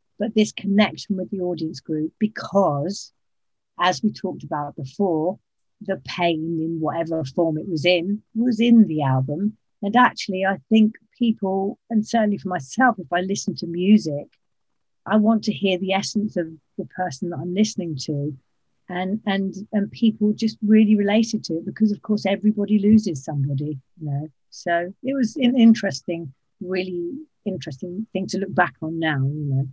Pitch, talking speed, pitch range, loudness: 190 Hz, 170 wpm, 160-210 Hz, -22 LUFS